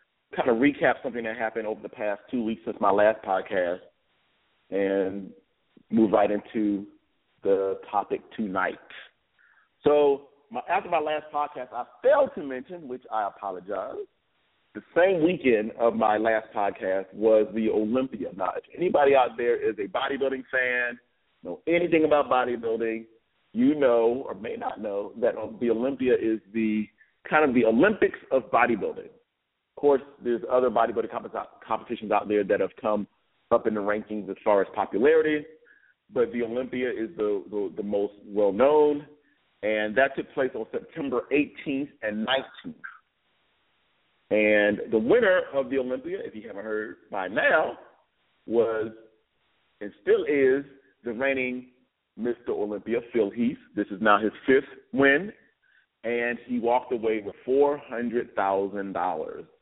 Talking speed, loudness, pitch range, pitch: 150 wpm, -26 LUFS, 110-150 Hz, 125 Hz